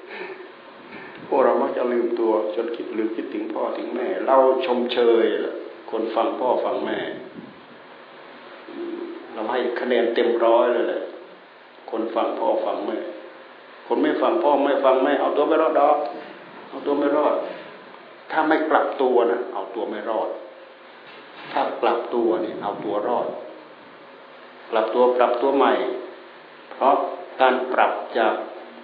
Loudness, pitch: -22 LUFS, 340 Hz